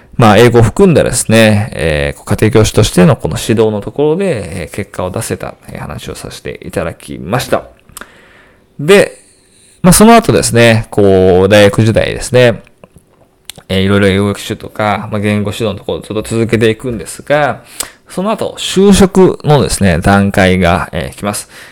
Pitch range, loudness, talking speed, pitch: 100-120 Hz, -10 LUFS, 325 characters per minute, 110 Hz